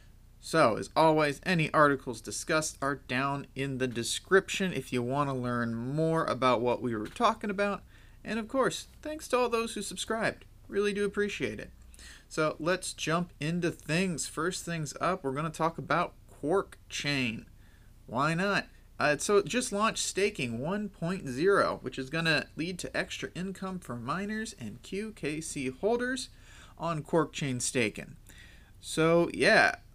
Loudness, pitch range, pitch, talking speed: -30 LUFS, 130-195 Hz, 155 Hz, 160 wpm